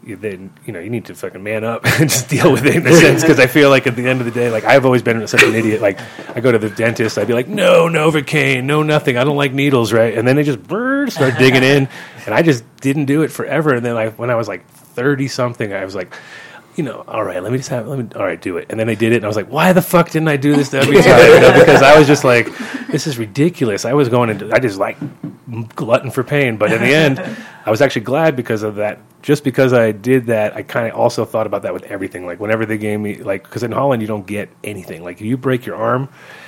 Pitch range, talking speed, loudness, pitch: 115-145 Hz, 285 wpm, -13 LUFS, 130 Hz